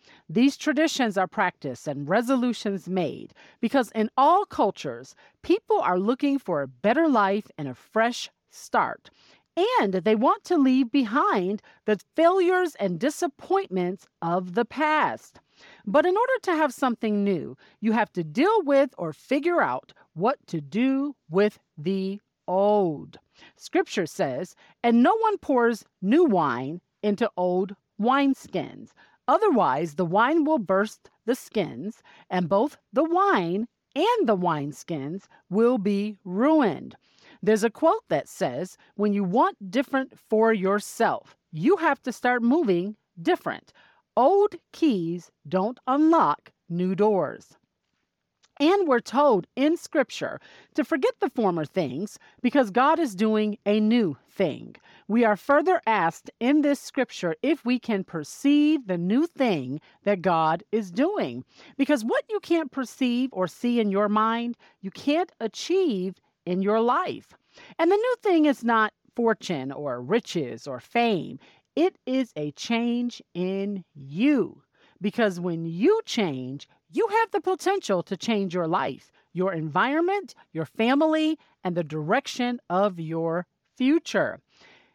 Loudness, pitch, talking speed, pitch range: -25 LUFS, 230 Hz, 140 wpm, 190-290 Hz